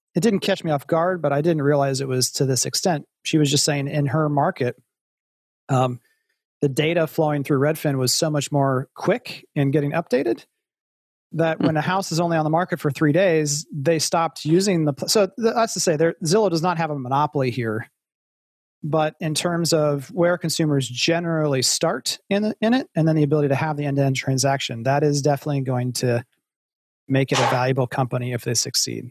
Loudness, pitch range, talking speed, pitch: -21 LUFS, 135-165 Hz, 205 wpm, 150 Hz